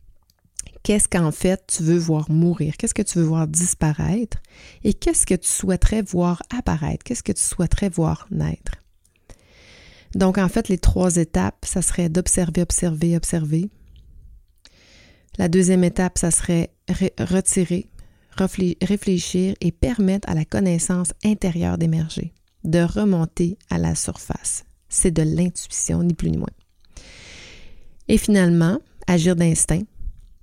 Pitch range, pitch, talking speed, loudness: 155-185 Hz, 175 Hz, 135 wpm, -20 LUFS